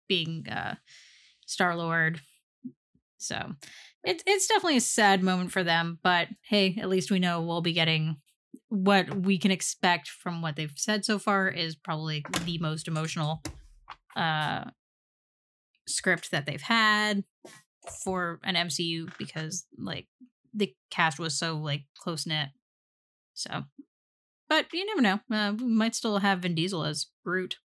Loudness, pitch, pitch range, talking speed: -28 LUFS, 180 Hz, 160-205 Hz, 145 wpm